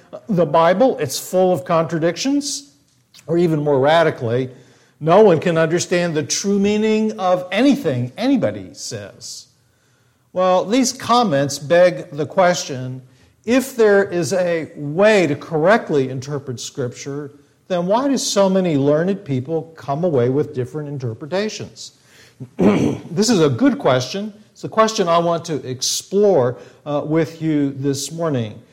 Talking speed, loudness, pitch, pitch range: 135 wpm, -18 LUFS, 160 Hz, 140-195 Hz